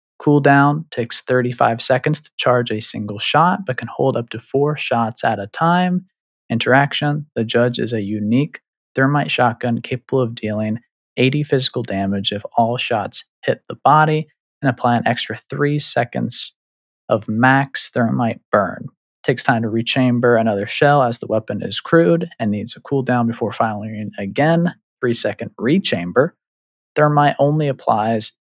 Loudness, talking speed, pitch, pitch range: -18 LUFS, 155 wpm, 125 Hz, 115-145 Hz